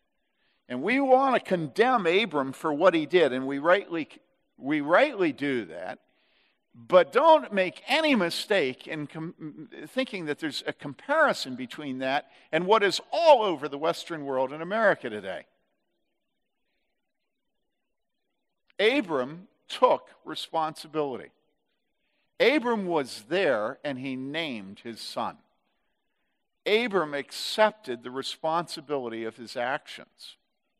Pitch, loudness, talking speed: 165 Hz, -26 LUFS, 115 wpm